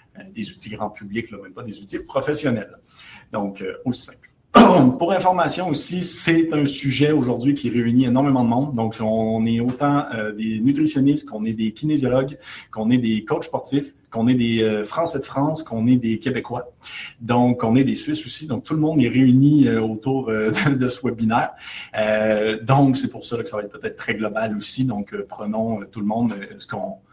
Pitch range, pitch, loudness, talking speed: 110-140 Hz, 120 Hz, -20 LUFS, 185 wpm